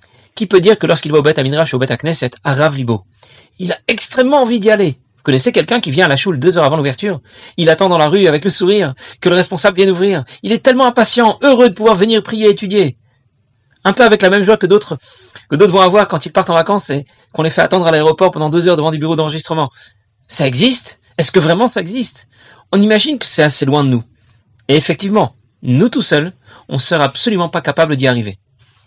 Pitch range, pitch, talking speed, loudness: 130-200 Hz, 165 Hz, 245 wpm, -12 LUFS